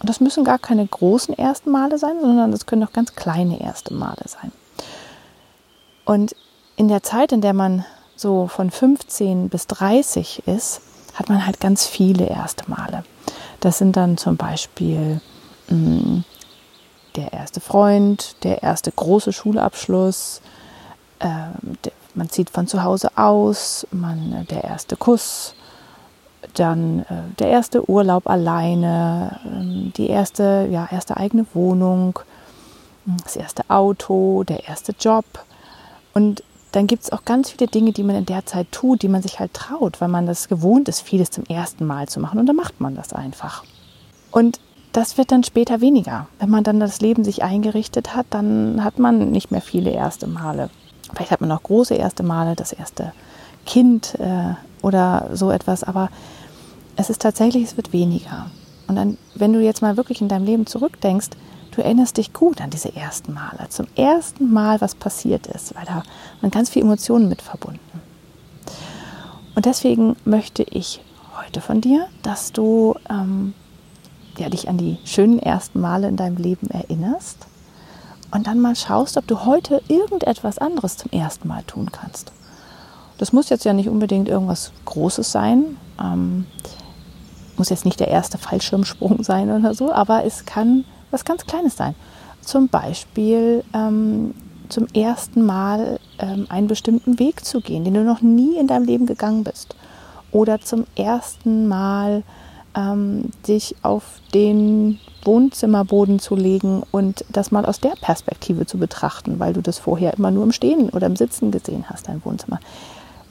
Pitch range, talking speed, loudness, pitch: 185-230 Hz, 165 wpm, -19 LUFS, 210 Hz